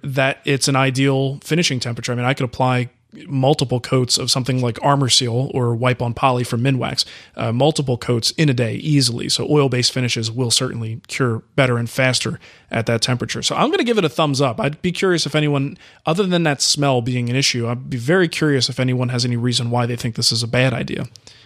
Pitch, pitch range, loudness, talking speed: 130 Hz, 120-140 Hz, -18 LUFS, 230 wpm